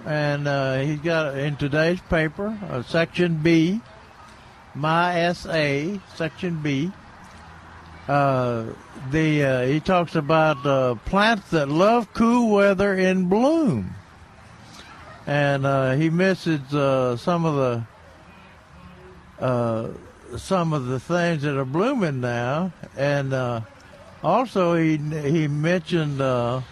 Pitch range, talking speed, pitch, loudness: 125-175 Hz, 120 wpm, 150 Hz, -22 LUFS